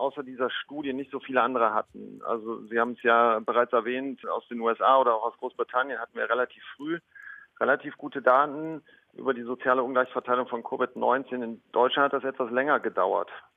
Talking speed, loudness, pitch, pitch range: 185 wpm, -27 LUFS, 130 Hz, 120-140 Hz